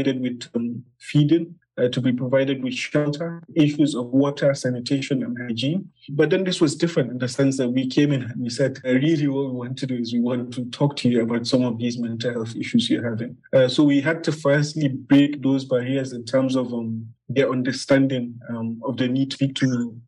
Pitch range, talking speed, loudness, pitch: 125-145 Hz, 225 wpm, -22 LUFS, 130 Hz